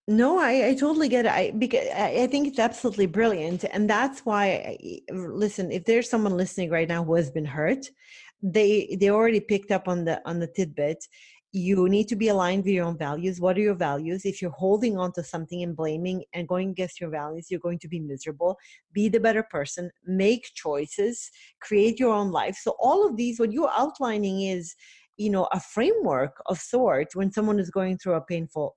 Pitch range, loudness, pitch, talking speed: 175-220 Hz, -25 LUFS, 195 Hz, 210 wpm